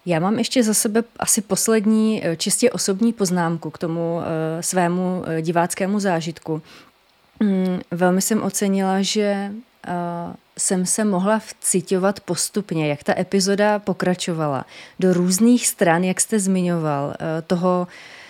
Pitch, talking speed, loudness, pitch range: 185 Hz, 115 wpm, -20 LUFS, 170-210 Hz